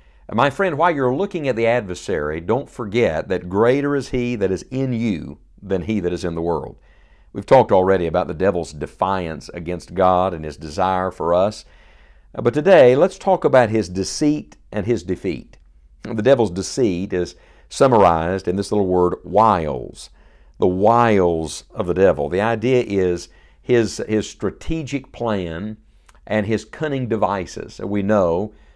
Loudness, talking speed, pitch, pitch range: -19 LUFS, 160 wpm, 105 Hz, 90-120 Hz